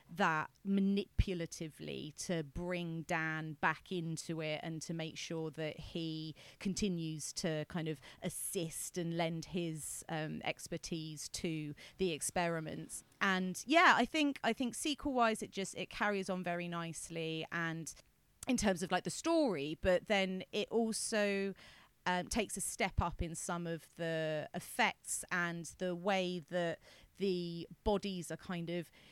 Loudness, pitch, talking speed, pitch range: -37 LUFS, 175 Hz, 150 wpm, 160-195 Hz